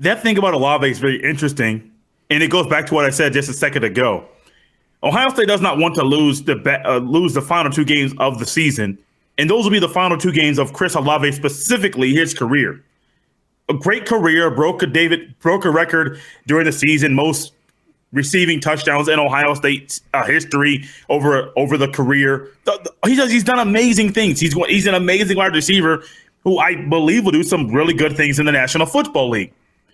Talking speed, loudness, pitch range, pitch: 205 wpm, -16 LUFS, 140-175 Hz, 155 Hz